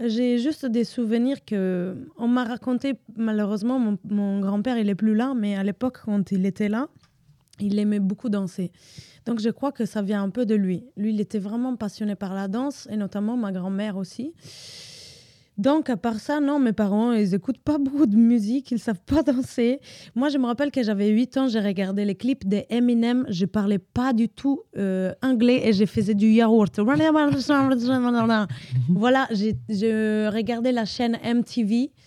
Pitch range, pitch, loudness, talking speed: 205-250 Hz, 225 Hz, -23 LUFS, 190 wpm